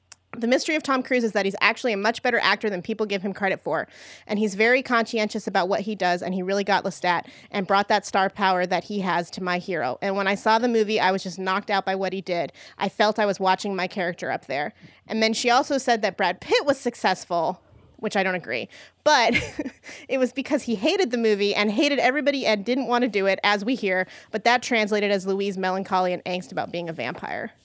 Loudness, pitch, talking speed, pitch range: -23 LUFS, 210 Hz, 245 wpm, 190-235 Hz